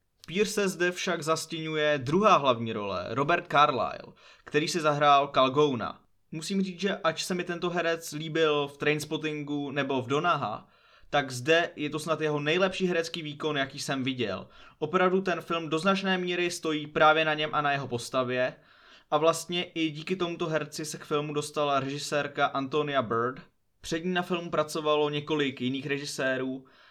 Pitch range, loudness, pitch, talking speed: 145-170 Hz, -28 LUFS, 155 Hz, 165 wpm